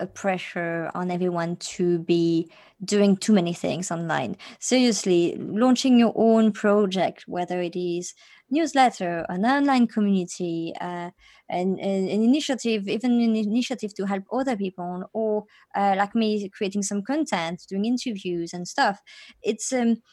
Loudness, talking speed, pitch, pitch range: -24 LUFS, 140 wpm, 200 Hz, 180-230 Hz